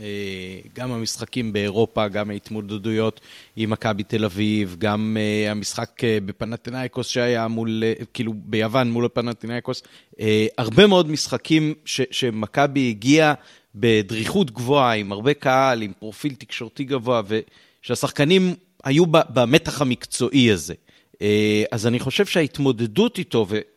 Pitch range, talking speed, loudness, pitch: 110-135 Hz, 120 wpm, -21 LUFS, 120 Hz